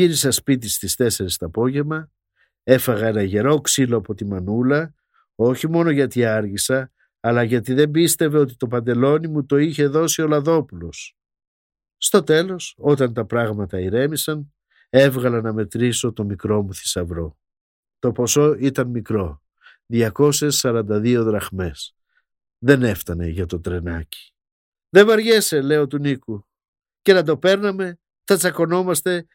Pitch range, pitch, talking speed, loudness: 105-150 Hz, 125 Hz, 135 wpm, -19 LUFS